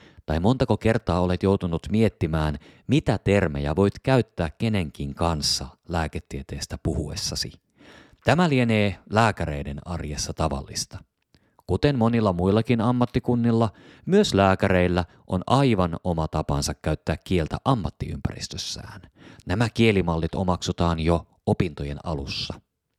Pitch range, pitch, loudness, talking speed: 80-115 Hz, 90 Hz, -24 LUFS, 100 wpm